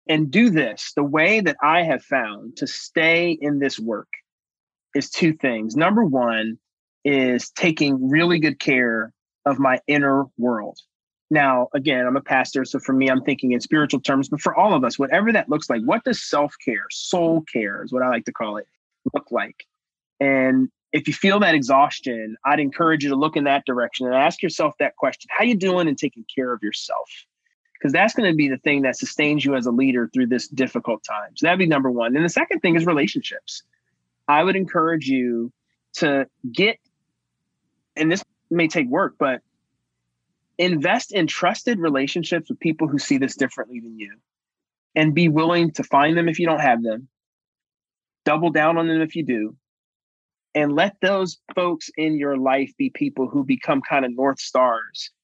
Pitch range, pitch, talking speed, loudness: 130-170 Hz, 145 Hz, 195 wpm, -20 LUFS